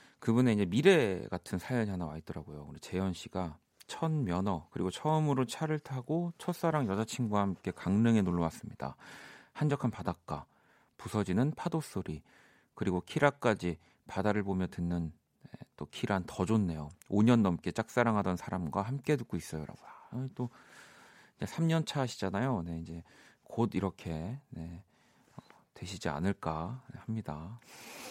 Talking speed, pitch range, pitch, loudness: 300 characters per minute, 90-130 Hz, 105 Hz, -33 LUFS